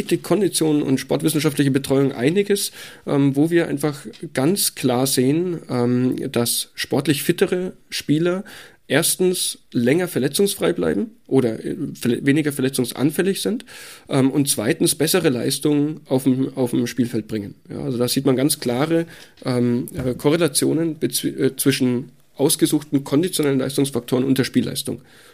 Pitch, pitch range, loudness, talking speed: 145 Hz, 130-165 Hz, -20 LUFS, 110 wpm